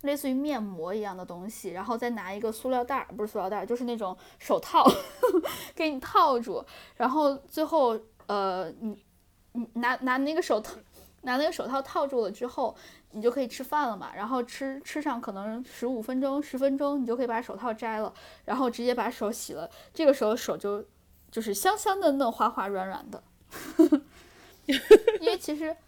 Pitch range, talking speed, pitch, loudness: 220-290 Hz, 275 characters per minute, 250 Hz, -28 LUFS